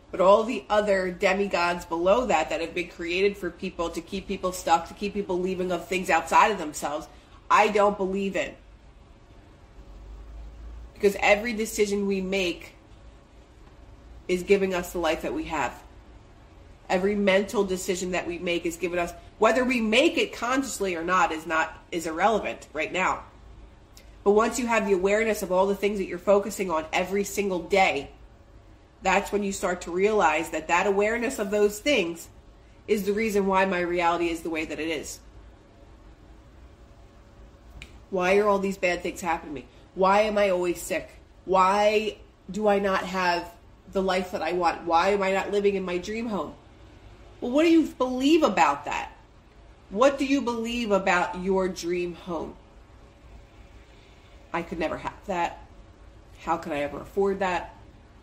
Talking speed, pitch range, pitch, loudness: 170 wpm, 165-200 Hz, 185 Hz, -25 LUFS